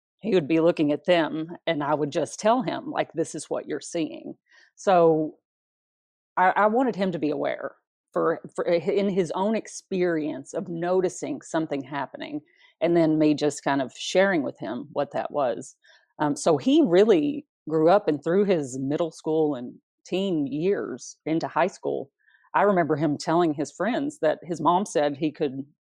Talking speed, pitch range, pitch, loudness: 180 wpm, 155-200 Hz, 170 Hz, -25 LUFS